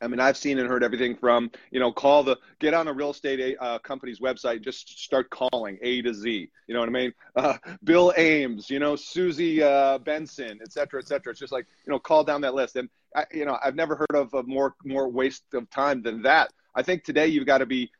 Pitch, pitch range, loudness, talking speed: 135 Hz, 125-150 Hz, -25 LUFS, 250 wpm